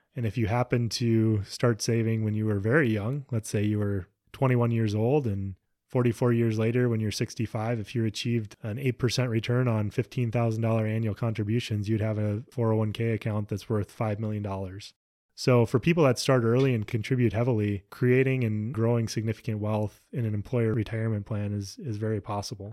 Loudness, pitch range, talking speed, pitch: -27 LUFS, 105-120 Hz, 180 wpm, 115 Hz